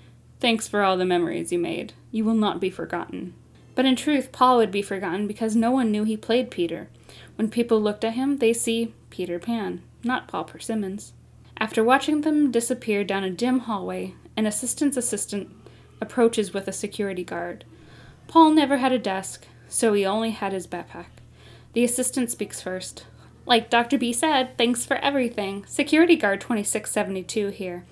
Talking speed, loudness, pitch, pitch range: 170 wpm, -24 LUFS, 225 Hz, 195-250 Hz